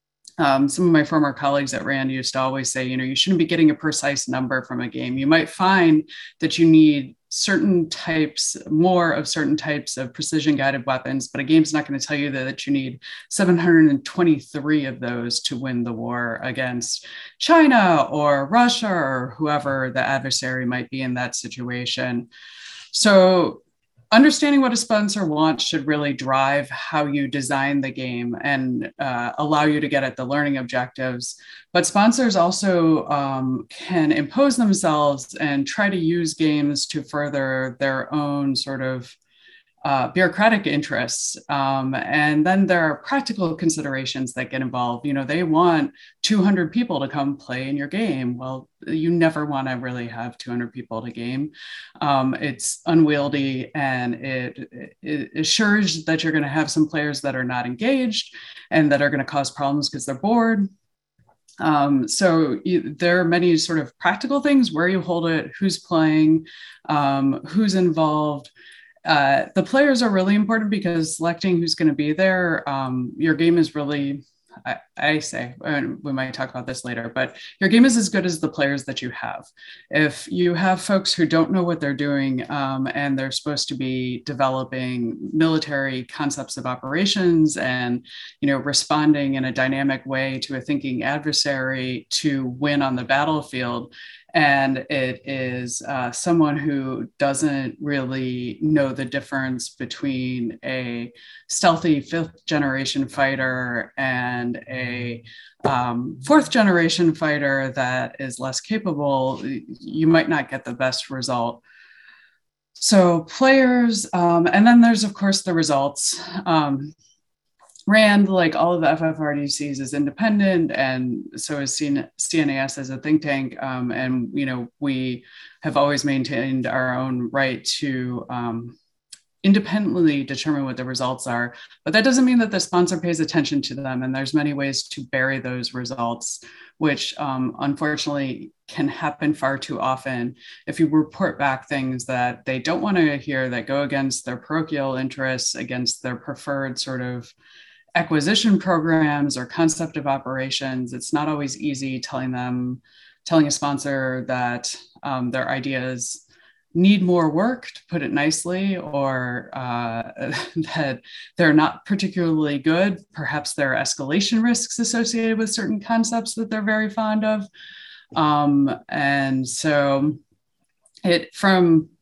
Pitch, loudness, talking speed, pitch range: 145 Hz, -21 LUFS, 160 wpm, 130-170 Hz